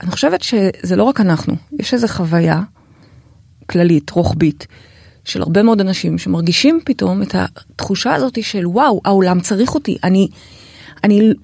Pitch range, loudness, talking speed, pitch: 145-220 Hz, -15 LUFS, 140 wpm, 185 Hz